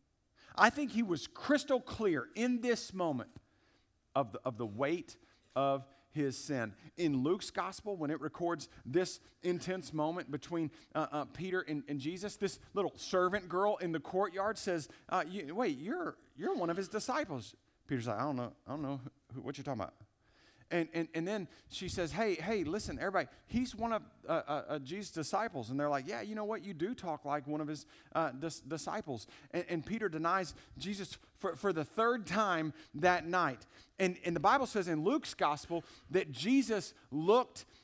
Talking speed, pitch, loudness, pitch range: 190 wpm, 165 Hz, -37 LUFS, 140-195 Hz